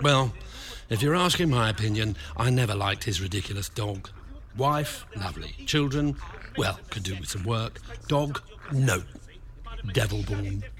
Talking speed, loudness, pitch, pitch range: 140 wpm, -27 LUFS, 110 Hz, 100-130 Hz